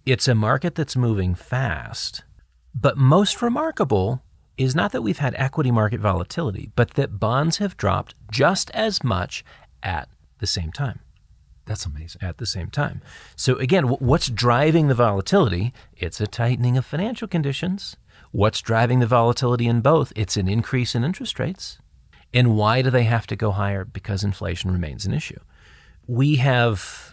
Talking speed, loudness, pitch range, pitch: 165 wpm, -22 LUFS, 105-140 Hz, 120 Hz